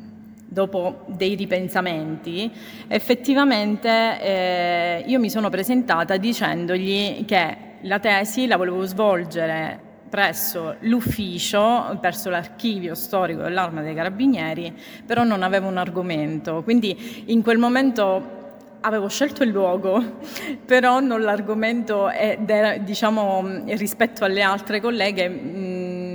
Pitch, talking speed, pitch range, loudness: 200 Hz, 110 wpm, 185-230 Hz, -21 LUFS